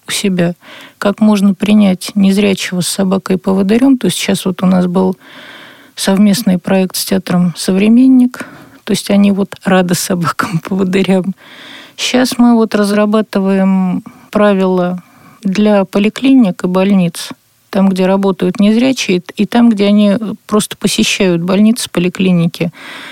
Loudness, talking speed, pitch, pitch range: -12 LUFS, 130 wpm, 195 Hz, 185-215 Hz